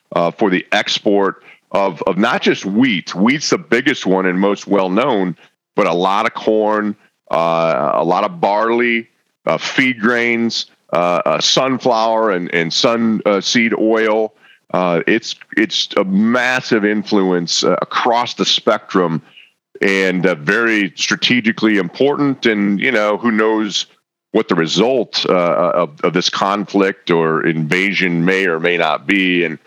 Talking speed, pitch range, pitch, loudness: 150 wpm, 95-115 Hz, 105 Hz, -15 LUFS